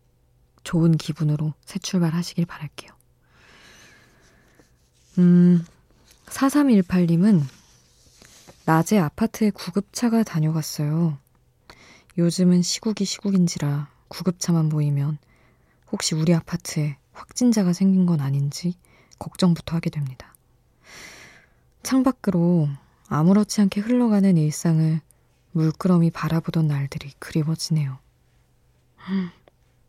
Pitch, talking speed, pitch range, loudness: 165 Hz, 225 characters per minute, 150-185 Hz, -22 LUFS